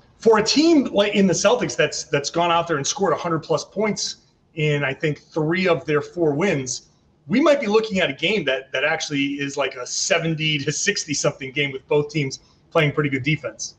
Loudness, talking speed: -21 LUFS, 215 wpm